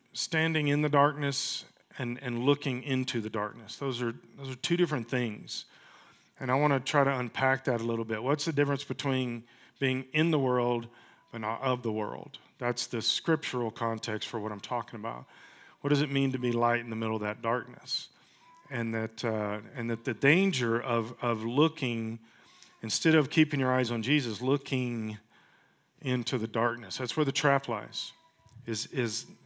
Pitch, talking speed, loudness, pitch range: 125 Hz, 185 wpm, -30 LUFS, 115-140 Hz